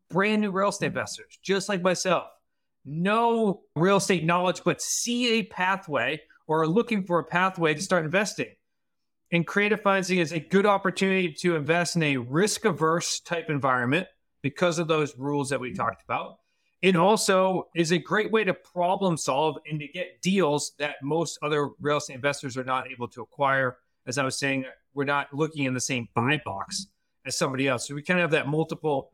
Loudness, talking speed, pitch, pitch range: -26 LUFS, 195 wpm, 170 Hz, 145-190 Hz